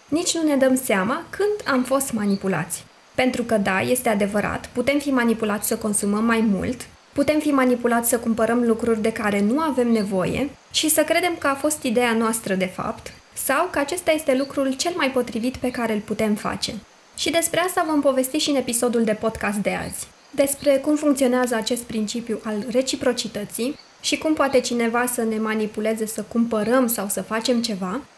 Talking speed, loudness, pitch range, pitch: 185 wpm, -21 LUFS, 220-280 Hz, 245 Hz